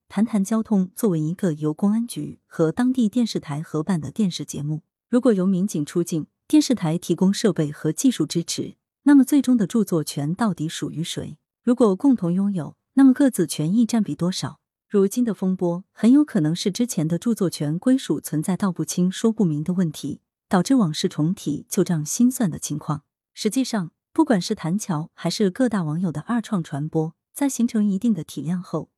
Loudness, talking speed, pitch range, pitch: -22 LUFS, 295 characters per minute, 160-225 Hz, 185 Hz